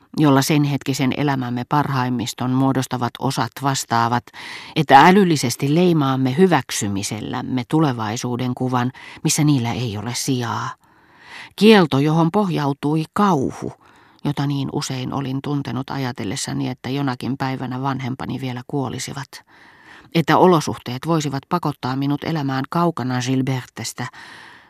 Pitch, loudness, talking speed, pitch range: 135 Hz, -20 LUFS, 105 wpm, 125-145 Hz